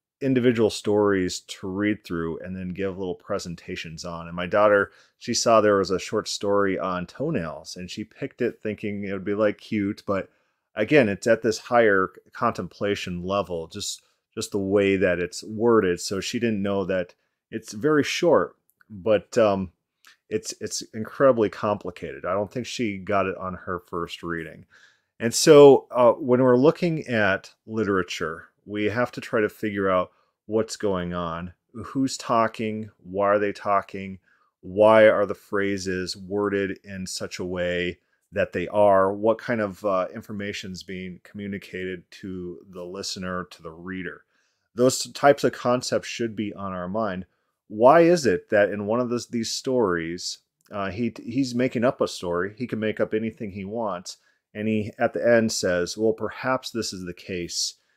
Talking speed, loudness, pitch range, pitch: 175 wpm, -24 LUFS, 95-110 Hz, 100 Hz